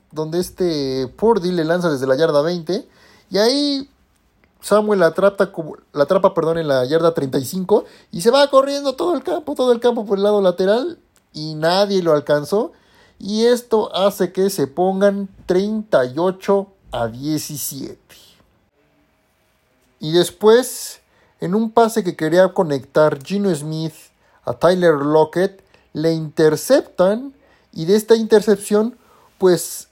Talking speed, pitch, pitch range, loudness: 130 wpm, 185 Hz, 160-215 Hz, -17 LUFS